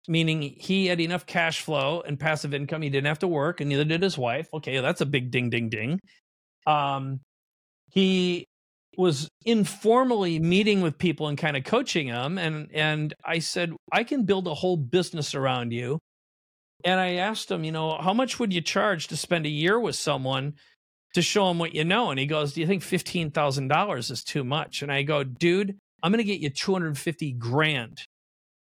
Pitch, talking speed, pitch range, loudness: 160 Hz, 205 wpm, 145-185 Hz, -26 LUFS